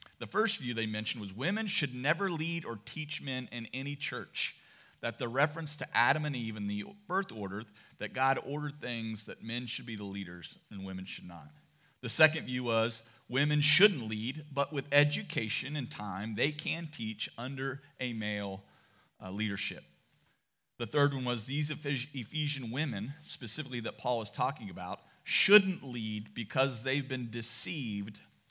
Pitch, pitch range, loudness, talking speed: 125 Hz, 110-145 Hz, -33 LUFS, 165 wpm